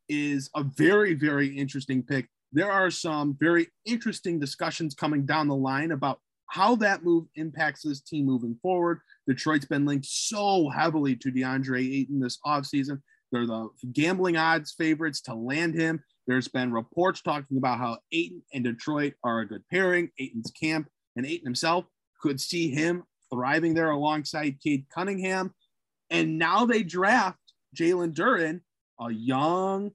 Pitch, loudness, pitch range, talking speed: 150 Hz, -27 LUFS, 135-170 Hz, 155 wpm